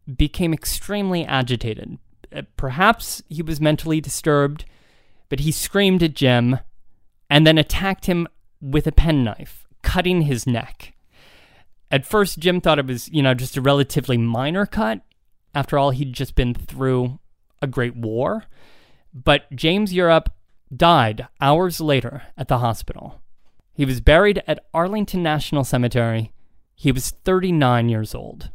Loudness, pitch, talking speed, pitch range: -20 LUFS, 140 Hz, 140 wpm, 125-165 Hz